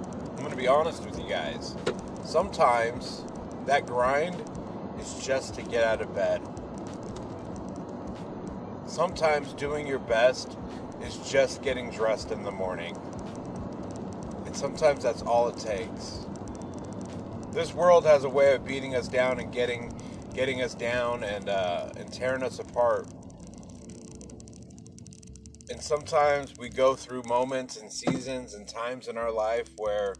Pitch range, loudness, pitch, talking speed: 115-135 Hz, -29 LUFS, 125 Hz, 135 wpm